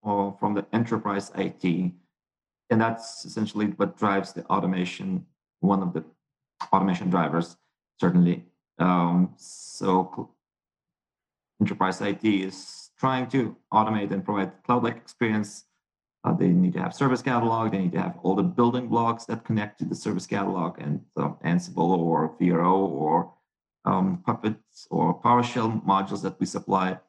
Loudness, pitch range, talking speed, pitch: -26 LUFS, 90-115 Hz, 145 wpm, 100 Hz